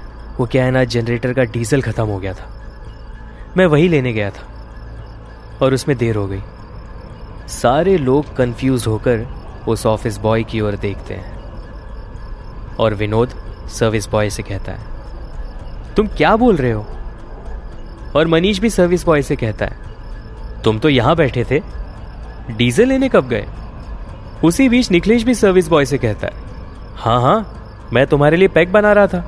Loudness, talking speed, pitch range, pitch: -15 LUFS, 160 wpm, 105-150 Hz, 115 Hz